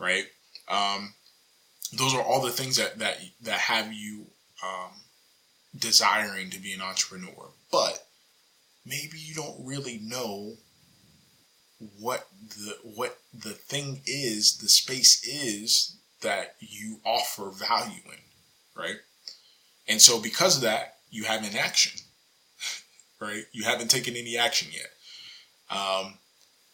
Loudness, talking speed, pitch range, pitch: -25 LUFS, 125 wpm, 100-120 Hz, 110 Hz